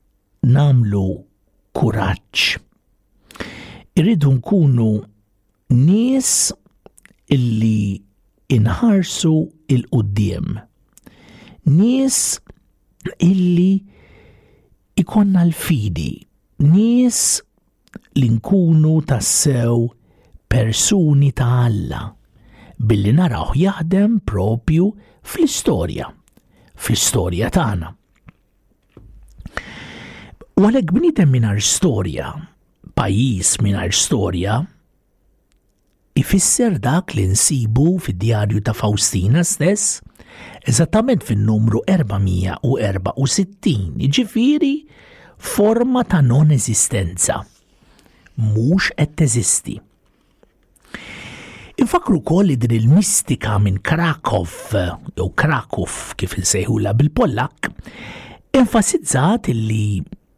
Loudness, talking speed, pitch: -17 LUFS, 70 wpm, 130 Hz